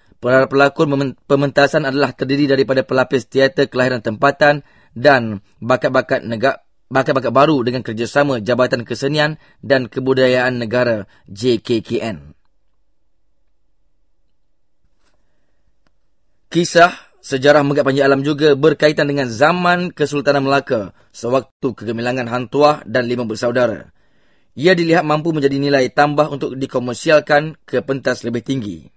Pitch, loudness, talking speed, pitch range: 135 Hz, -16 LUFS, 105 wpm, 125-145 Hz